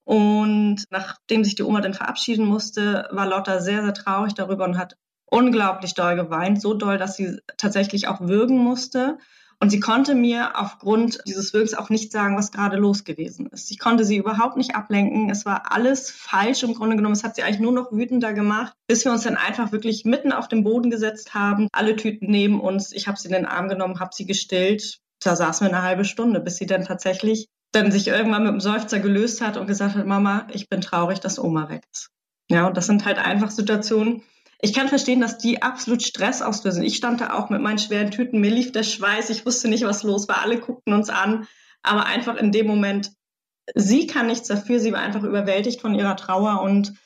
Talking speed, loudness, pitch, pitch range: 220 wpm, -21 LUFS, 210 Hz, 200-230 Hz